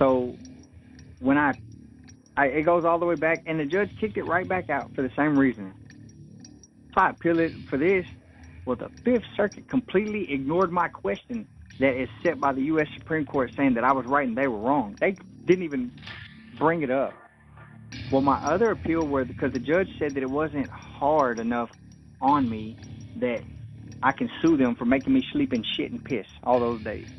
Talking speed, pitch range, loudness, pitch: 200 wpm, 120-175 Hz, -25 LUFS, 140 Hz